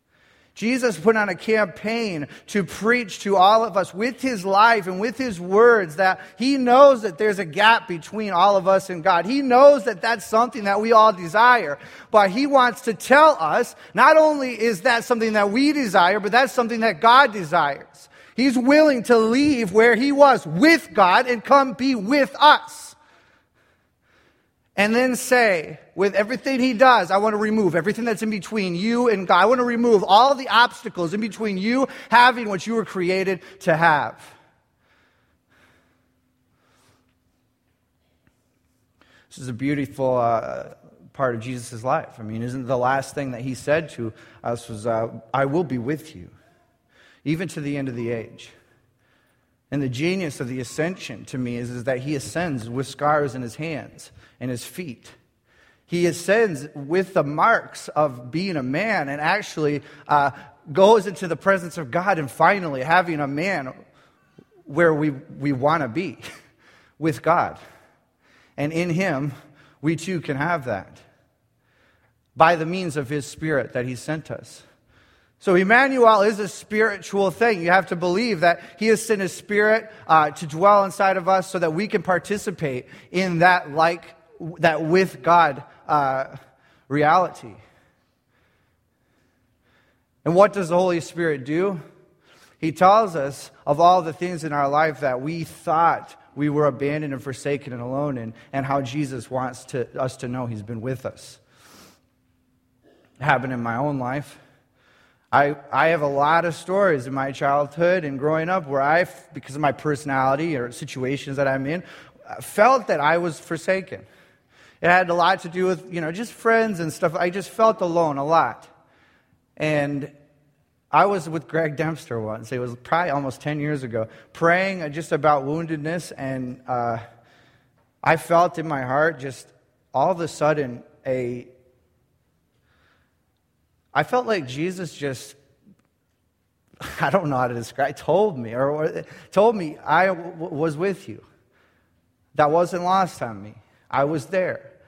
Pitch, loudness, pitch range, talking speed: 165 Hz, -20 LUFS, 135-200 Hz, 165 wpm